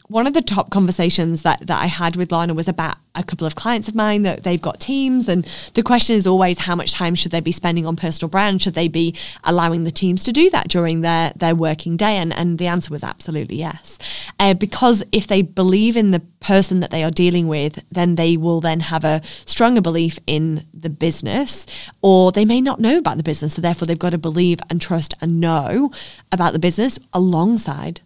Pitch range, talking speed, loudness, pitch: 165-195 Hz, 225 wpm, -17 LUFS, 175 Hz